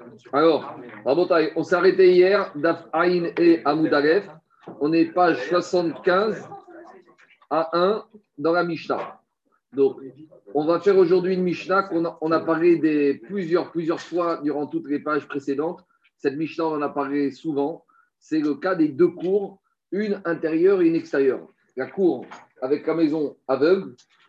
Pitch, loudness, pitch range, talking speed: 170 Hz, -22 LUFS, 155-200 Hz, 150 wpm